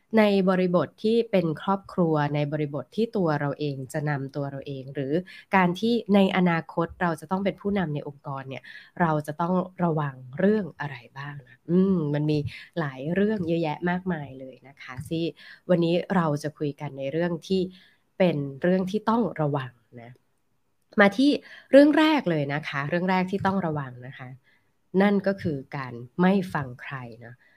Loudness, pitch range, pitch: -25 LUFS, 145-190 Hz, 165 Hz